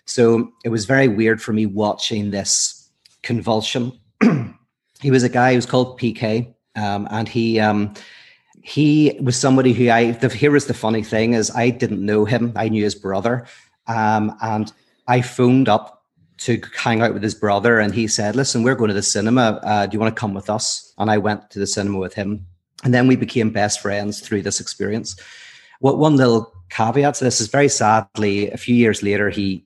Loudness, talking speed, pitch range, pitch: -18 LUFS, 205 wpm, 105-125 Hz, 110 Hz